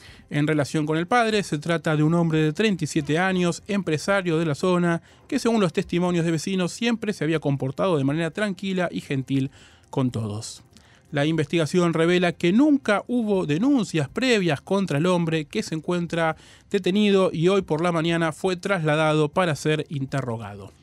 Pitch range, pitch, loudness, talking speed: 150-190 Hz, 165 Hz, -23 LUFS, 170 wpm